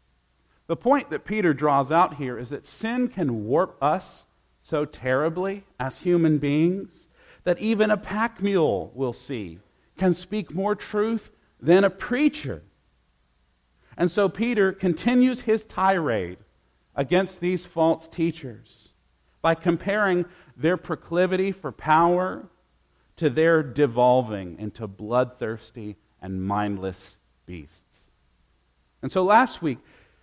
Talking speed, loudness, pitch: 120 wpm, -24 LUFS, 155 Hz